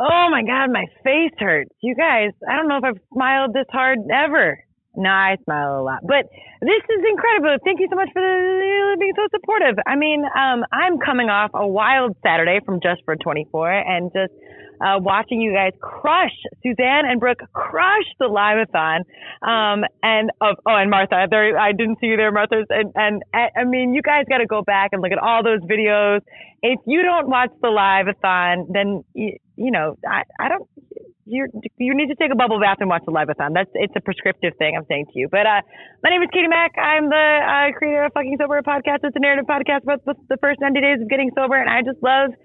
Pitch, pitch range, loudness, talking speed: 250 Hz, 205-290 Hz, -18 LUFS, 225 wpm